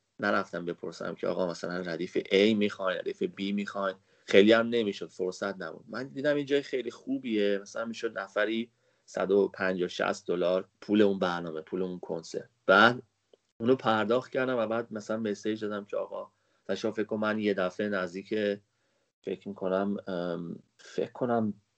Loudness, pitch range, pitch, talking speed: -30 LUFS, 95-115 Hz, 100 Hz, 155 wpm